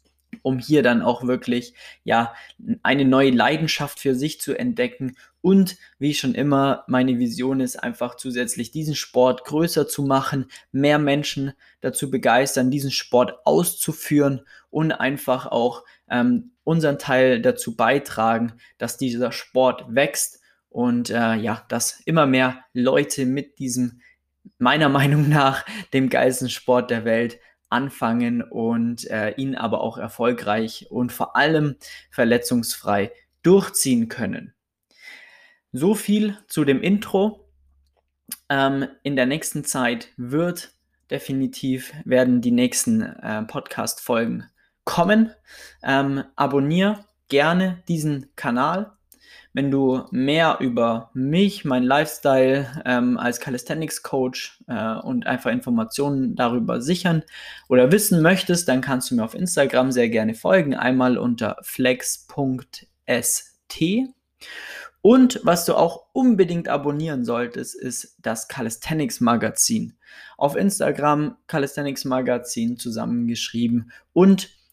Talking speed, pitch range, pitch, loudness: 120 wpm, 125-165 Hz, 135 Hz, -21 LUFS